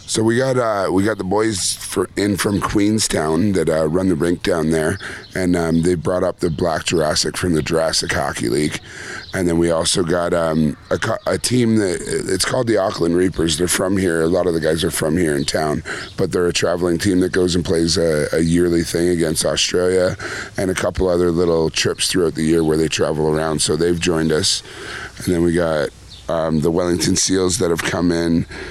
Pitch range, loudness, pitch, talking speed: 80-95 Hz, -18 LUFS, 85 Hz, 215 wpm